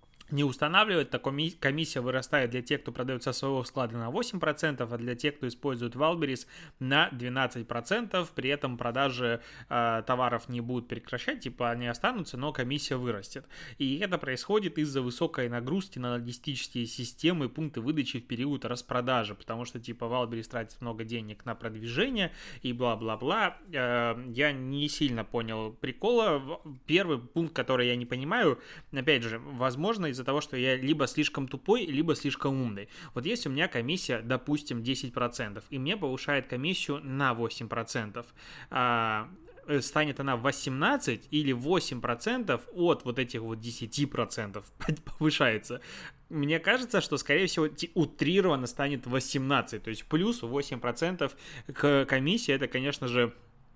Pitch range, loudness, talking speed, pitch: 120-150 Hz, -30 LUFS, 145 wpm, 130 Hz